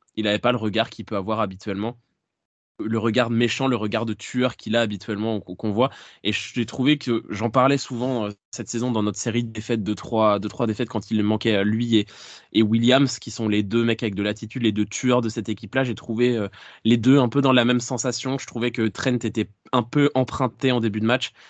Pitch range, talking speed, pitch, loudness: 105-125 Hz, 230 wpm, 115 Hz, -23 LUFS